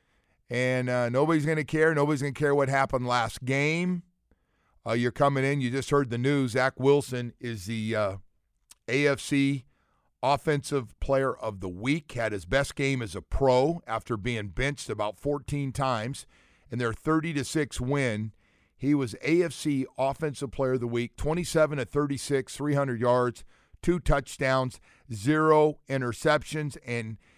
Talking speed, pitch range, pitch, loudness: 150 wpm, 120-145 Hz, 135 Hz, -28 LUFS